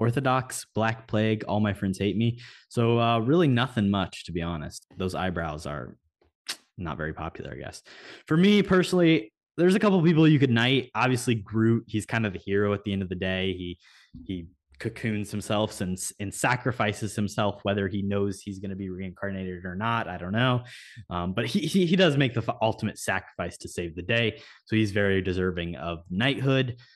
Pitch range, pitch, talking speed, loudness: 95-120 Hz, 105 Hz, 195 wpm, -26 LUFS